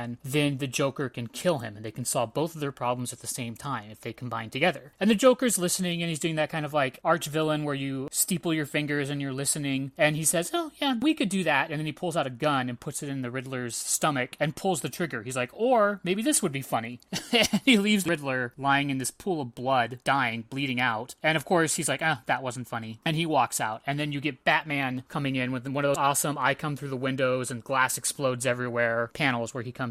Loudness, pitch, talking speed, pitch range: -27 LUFS, 140 Hz, 260 wpm, 125-160 Hz